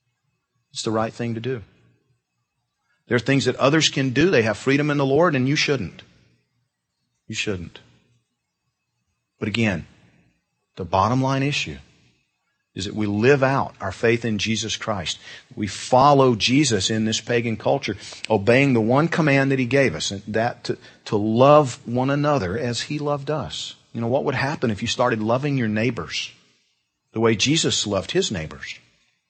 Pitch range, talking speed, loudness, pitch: 105-135 Hz, 170 wpm, -21 LUFS, 120 Hz